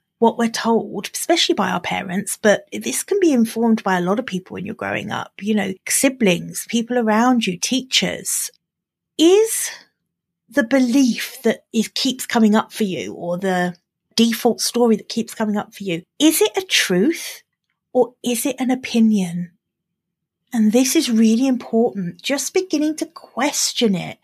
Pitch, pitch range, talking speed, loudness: 230 Hz, 200-265 Hz, 165 wpm, -19 LUFS